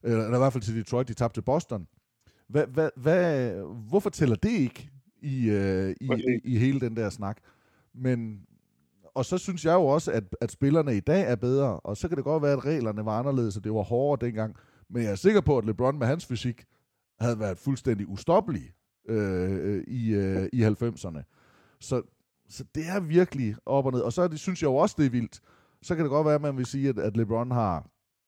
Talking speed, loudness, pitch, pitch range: 220 wpm, -27 LUFS, 120 Hz, 110-140 Hz